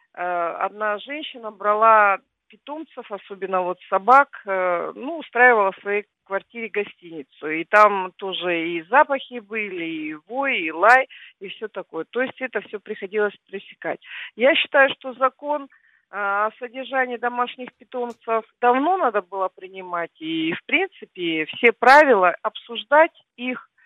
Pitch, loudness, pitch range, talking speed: 220 Hz, -20 LUFS, 195-260 Hz, 130 wpm